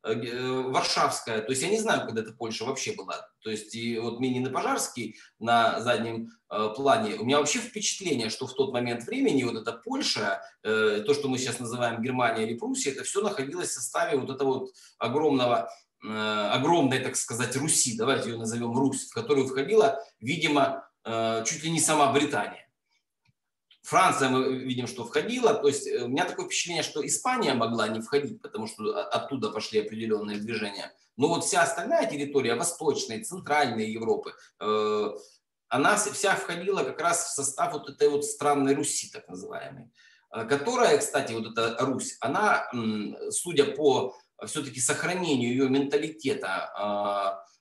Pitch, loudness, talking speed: 135 Hz, -27 LUFS, 155 wpm